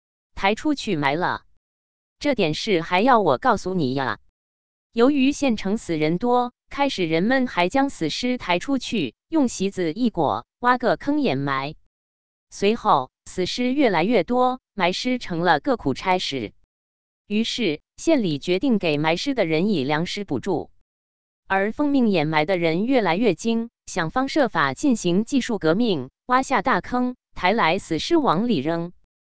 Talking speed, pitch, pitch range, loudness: 220 characters per minute, 190 Hz, 150-250 Hz, -22 LUFS